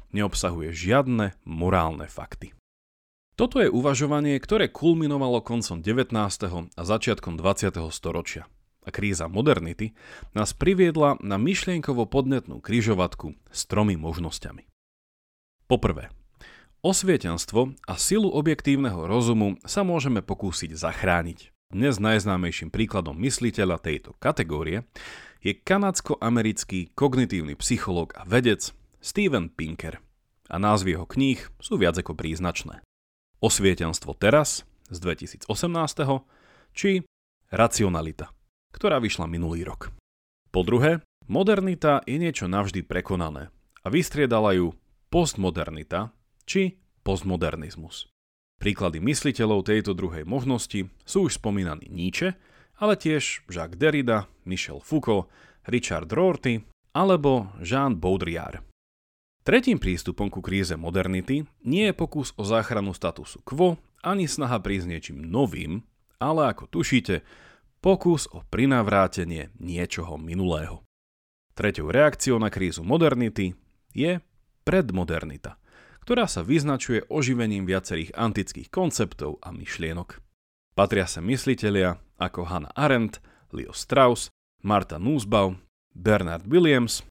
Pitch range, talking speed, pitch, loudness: 85-135 Hz, 105 wpm, 100 Hz, -25 LUFS